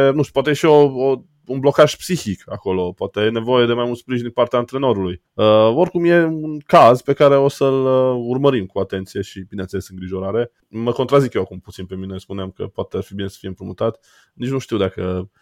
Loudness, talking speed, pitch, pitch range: -17 LUFS, 220 wpm, 120 Hz, 95-135 Hz